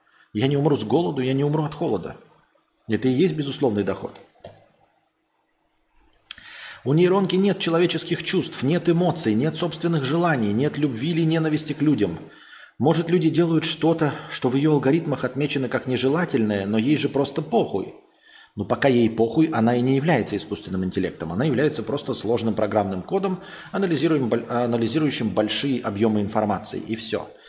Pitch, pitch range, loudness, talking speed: 140 Hz, 115-165 Hz, -22 LUFS, 150 wpm